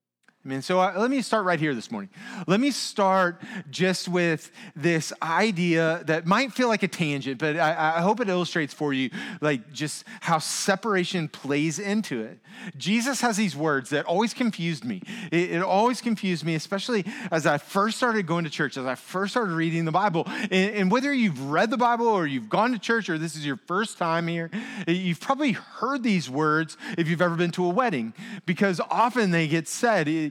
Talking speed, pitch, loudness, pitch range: 205 wpm, 185 Hz, -25 LUFS, 160-220 Hz